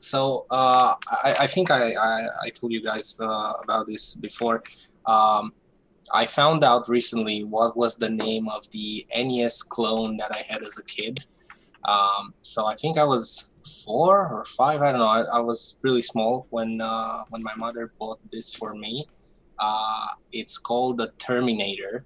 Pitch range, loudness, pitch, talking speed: 110-120 Hz, -24 LUFS, 115 Hz, 175 wpm